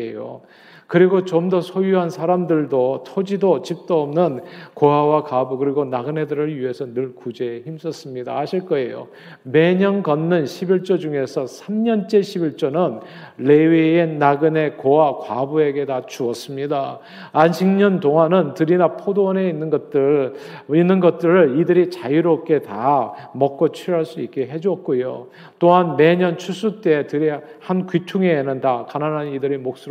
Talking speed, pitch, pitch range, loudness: 295 characters per minute, 160 Hz, 140-180 Hz, -19 LUFS